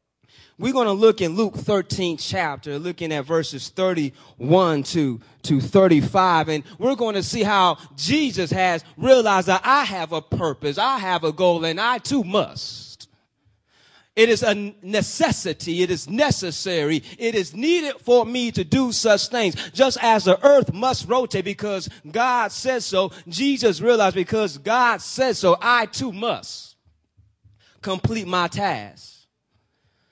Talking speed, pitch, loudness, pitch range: 145 wpm, 185 Hz, -20 LUFS, 155-230 Hz